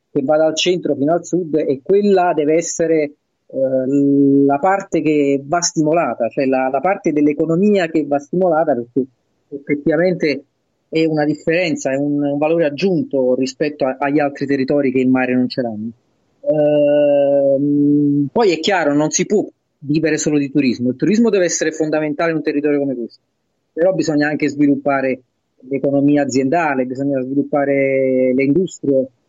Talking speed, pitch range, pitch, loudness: 155 wpm, 135-160 Hz, 145 Hz, -16 LUFS